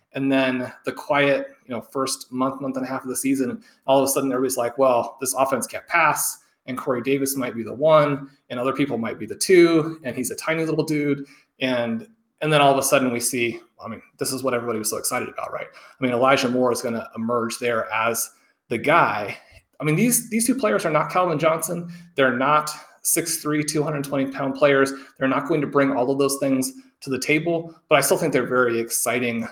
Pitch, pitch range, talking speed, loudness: 135 Hz, 130-155 Hz, 230 wpm, -22 LUFS